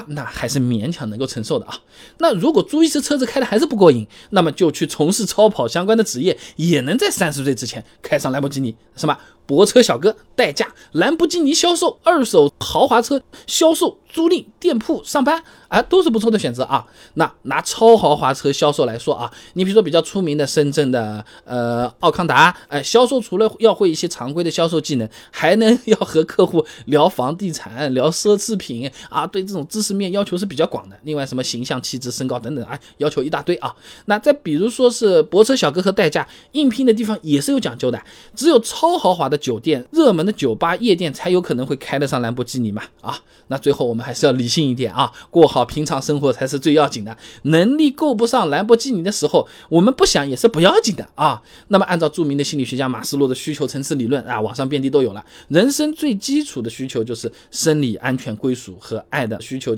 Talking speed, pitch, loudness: 330 characters per minute, 160 Hz, -17 LUFS